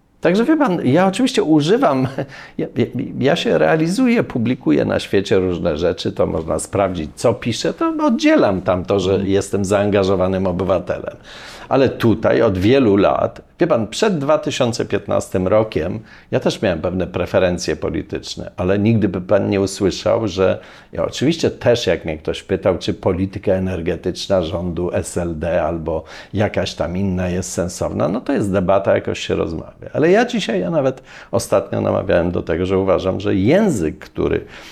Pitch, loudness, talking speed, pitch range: 100 Hz, -18 LUFS, 155 wpm, 95-135 Hz